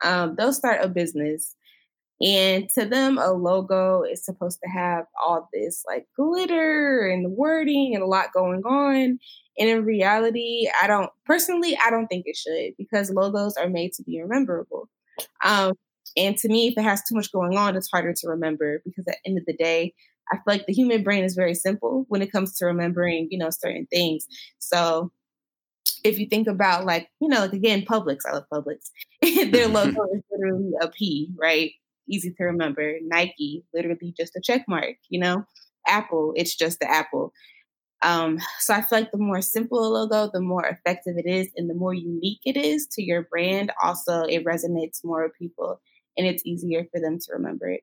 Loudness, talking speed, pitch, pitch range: -23 LUFS, 200 wpm, 190 Hz, 170-225 Hz